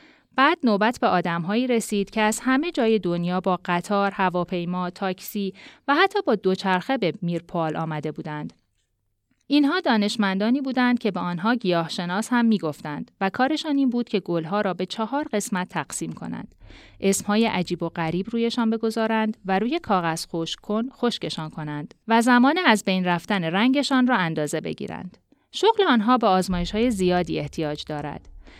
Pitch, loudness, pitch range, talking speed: 200 Hz, -23 LUFS, 175-235 Hz, 155 wpm